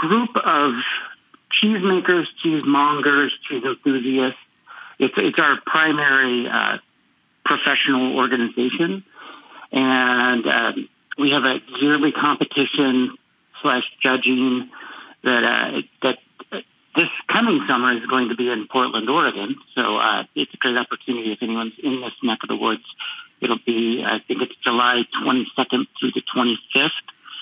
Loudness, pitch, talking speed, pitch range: -19 LUFS, 130 Hz, 130 wpm, 125-150 Hz